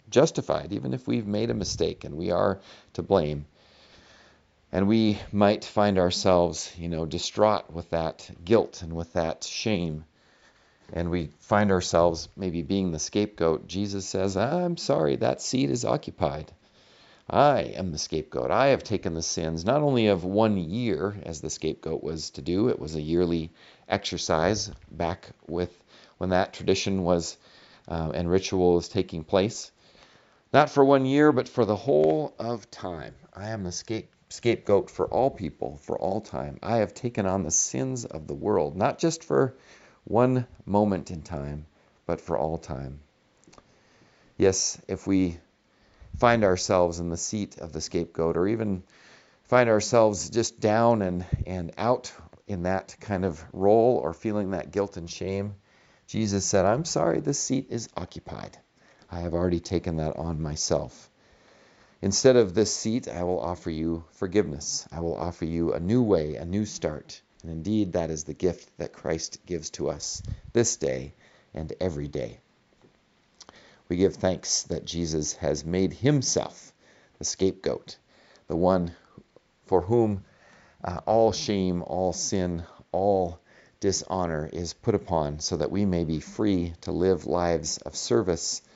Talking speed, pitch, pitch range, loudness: 160 wpm, 90 Hz, 80-105 Hz, -26 LUFS